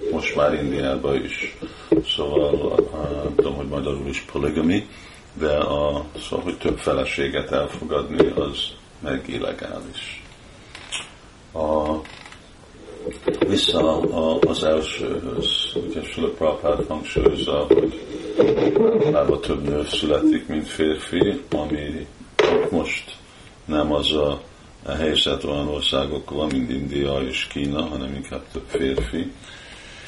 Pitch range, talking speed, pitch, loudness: 70-75 Hz, 110 wpm, 75 Hz, -22 LUFS